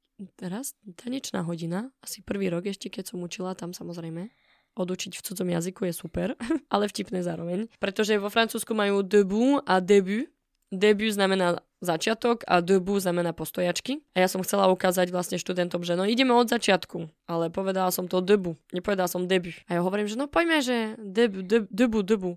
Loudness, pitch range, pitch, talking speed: -26 LUFS, 180-220 Hz, 190 Hz, 175 wpm